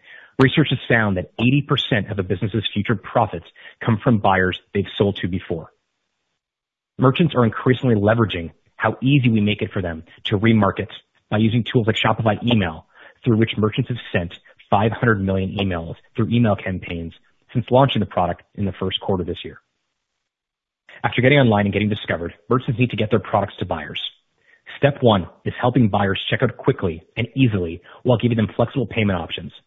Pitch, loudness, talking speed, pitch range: 110 Hz, -20 LUFS, 180 wpm, 100-120 Hz